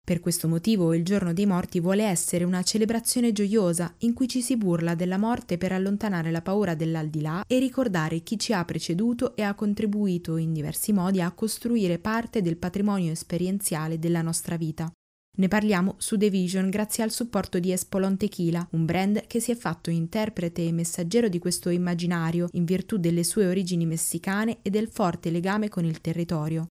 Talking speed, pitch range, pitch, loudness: 180 wpm, 170-210 Hz, 185 Hz, -26 LUFS